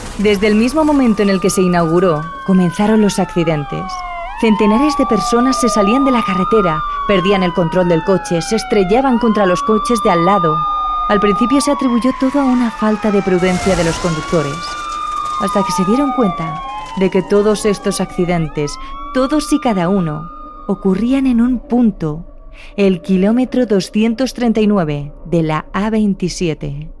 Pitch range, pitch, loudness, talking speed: 180-245 Hz, 205 Hz, -14 LUFS, 155 wpm